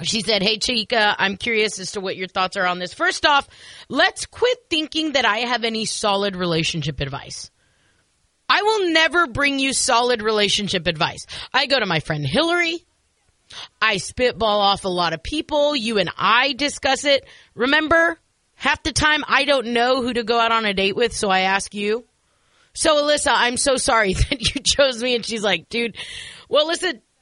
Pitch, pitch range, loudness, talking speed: 235 Hz, 200-285 Hz, -19 LUFS, 190 wpm